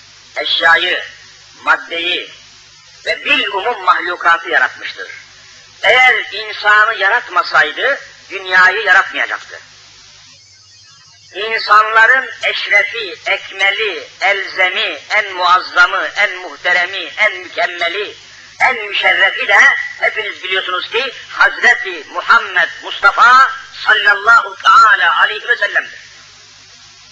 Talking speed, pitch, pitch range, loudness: 75 wpm, 200 Hz, 175-255 Hz, -12 LUFS